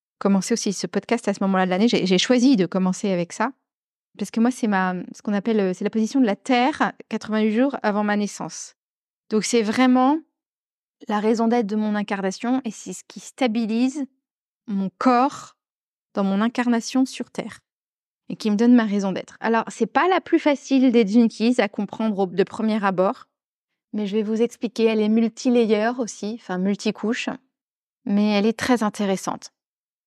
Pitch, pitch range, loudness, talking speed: 220 Hz, 205-245 Hz, -22 LUFS, 185 wpm